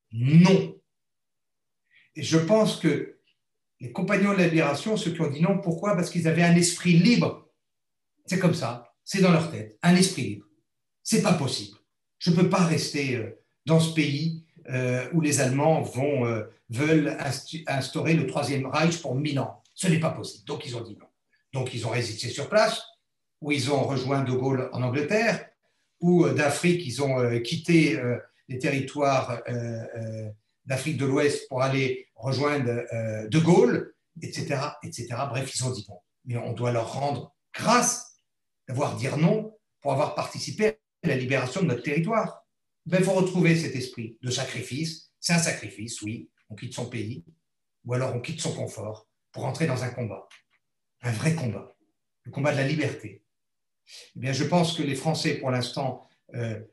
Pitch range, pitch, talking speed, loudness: 125-165 Hz, 140 Hz, 170 wpm, -26 LUFS